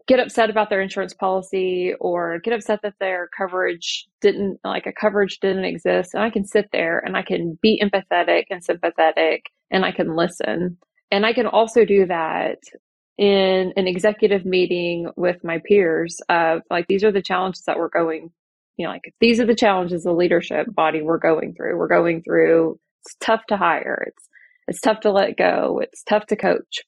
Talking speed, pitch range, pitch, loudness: 190 wpm, 175-215 Hz, 195 Hz, -20 LUFS